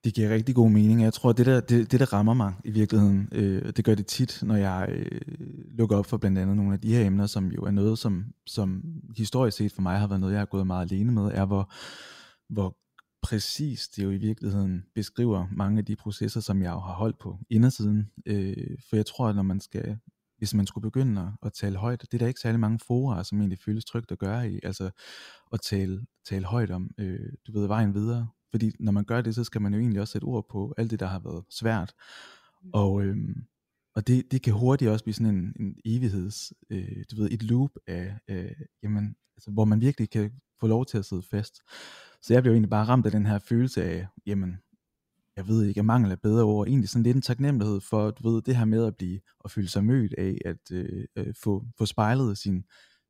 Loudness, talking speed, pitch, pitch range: -27 LUFS, 240 wpm, 105 Hz, 100-115 Hz